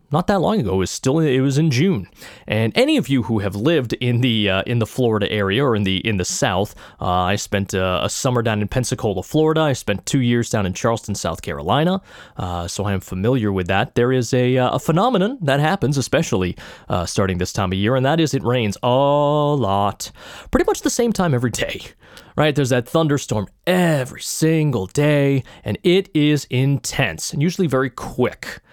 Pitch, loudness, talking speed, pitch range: 125 Hz, -19 LUFS, 205 wpm, 105-150 Hz